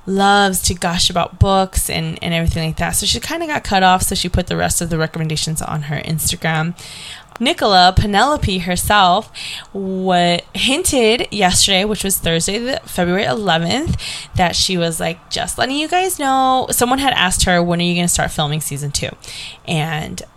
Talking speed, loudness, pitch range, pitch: 185 wpm, -16 LUFS, 160-200 Hz, 180 Hz